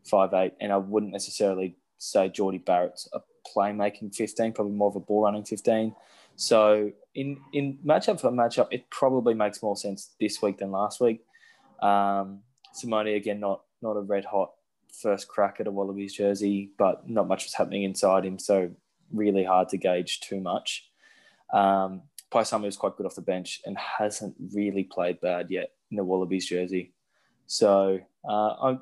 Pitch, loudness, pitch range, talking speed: 100 Hz, -27 LUFS, 95-105 Hz, 175 wpm